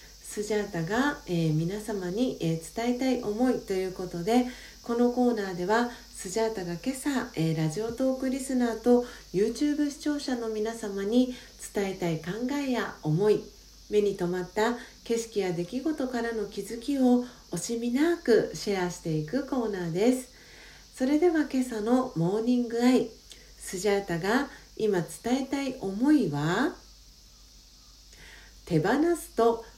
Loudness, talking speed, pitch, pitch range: -28 LUFS, 280 characters per minute, 230 Hz, 195-255 Hz